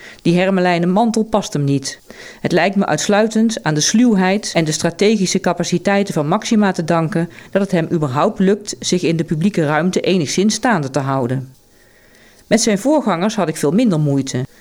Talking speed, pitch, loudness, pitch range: 175 wpm, 180 Hz, -16 LUFS, 150-205 Hz